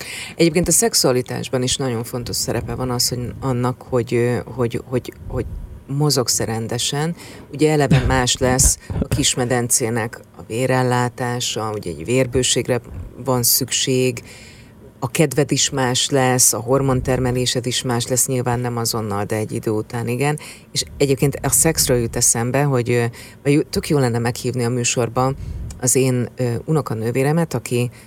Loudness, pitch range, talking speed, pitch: -19 LUFS, 120-130 Hz, 140 wpm, 125 Hz